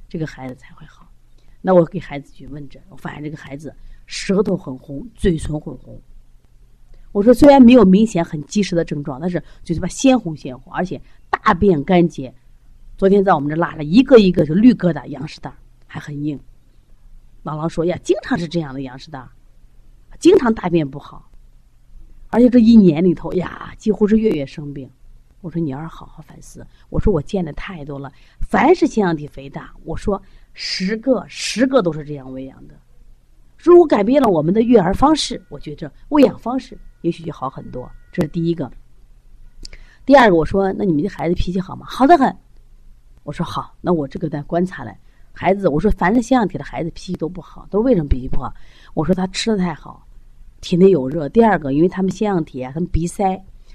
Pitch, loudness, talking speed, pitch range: 170 Hz, -16 LUFS, 290 characters per minute, 145-200 Hz